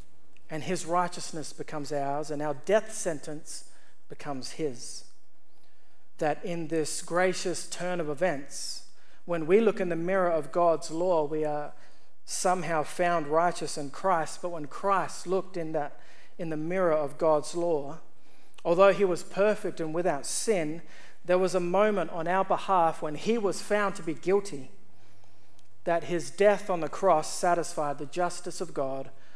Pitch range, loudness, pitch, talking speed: 150-185 Hz, -29 LUFS, 170 Hz, 160 wpm